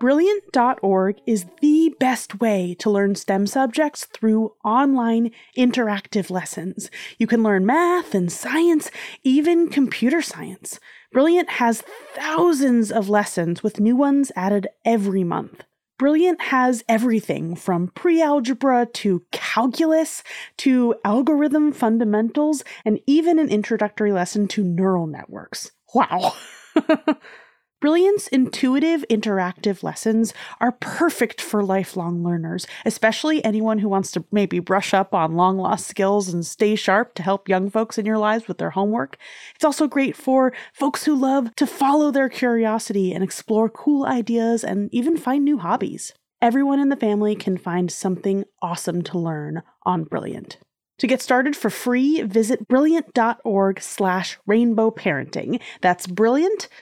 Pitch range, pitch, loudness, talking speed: 195-275 Hz, 225 Hz, -20 LUFS, 140 wpm